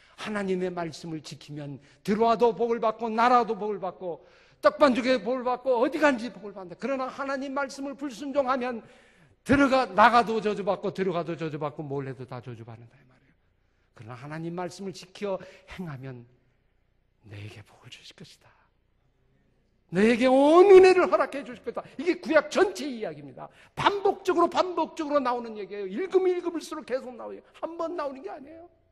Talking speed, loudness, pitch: 365 characters per minute, -25 LUFS, 230 Hz